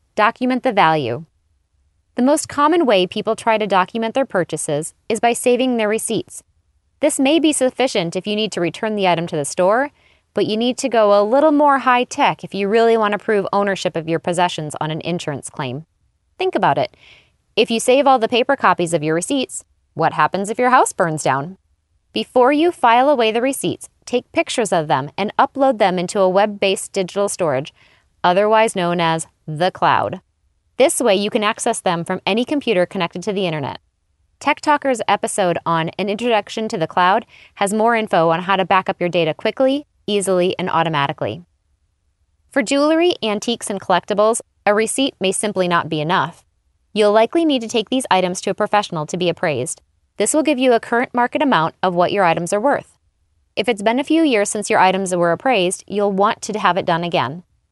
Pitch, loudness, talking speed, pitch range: 200 Hz, -17 LUFS, 200 wpm, 170-235 Hz